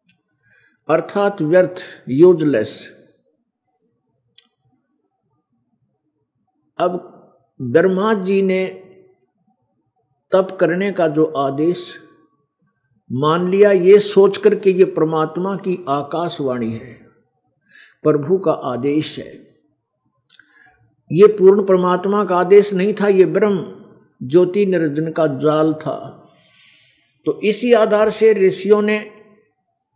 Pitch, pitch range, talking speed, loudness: 180 Hz, 155-200 Hz, 95 wpm, -16 LUFS